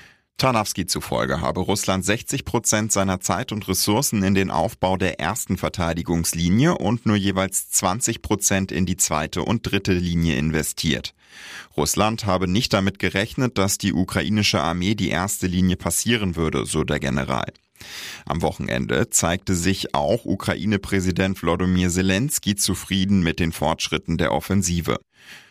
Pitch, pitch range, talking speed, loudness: 95 Hz, 85-100 Hz, 140 wpm, -21 LUFS